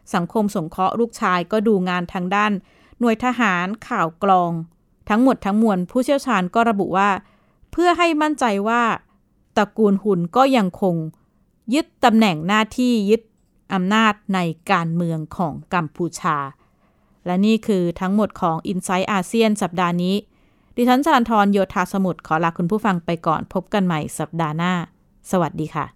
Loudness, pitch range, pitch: -20 LUFS, 175-220 Hz, 195 Hz